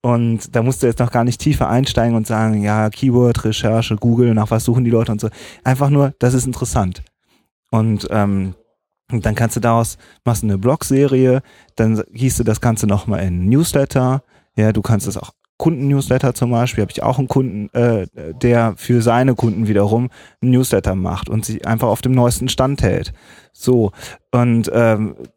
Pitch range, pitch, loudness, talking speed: 110-125 Hz, 120 Hz, -17 LUFS, 180 wpm